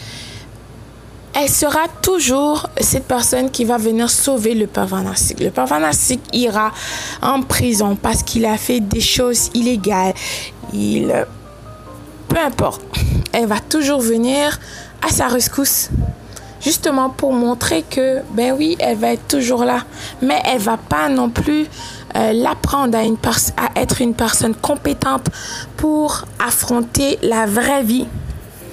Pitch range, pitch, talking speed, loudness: 165-265 Hz, 240 Hz, 135 wpm, -16 LUFS